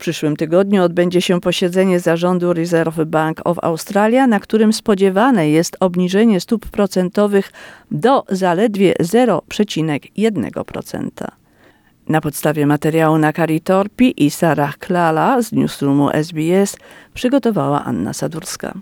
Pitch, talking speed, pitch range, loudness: 180 Hz, 115 wpm, 160-205 Hz, -16 LUFS